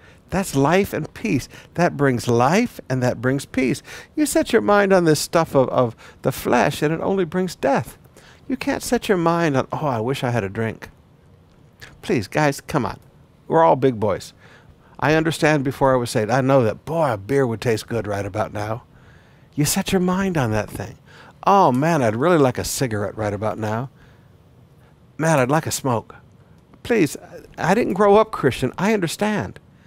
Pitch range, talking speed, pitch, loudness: 115-170 Hz, 195 wpm, 135 Hz, -20 LUFS